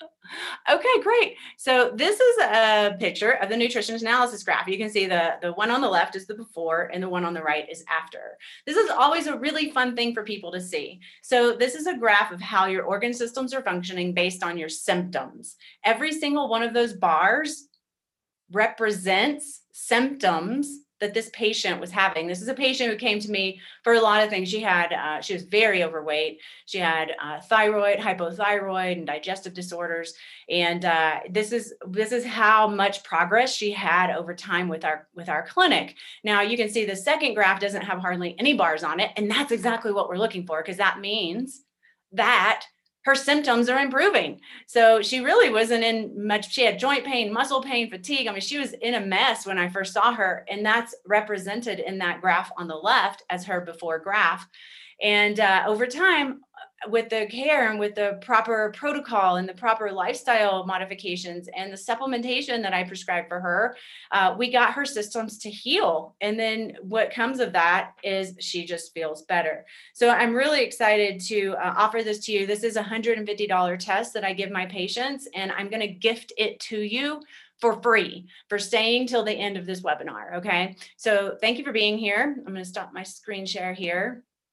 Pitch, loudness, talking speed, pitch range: 210 Hz, -24 LUFS, 200 wpm, 185-240 Hz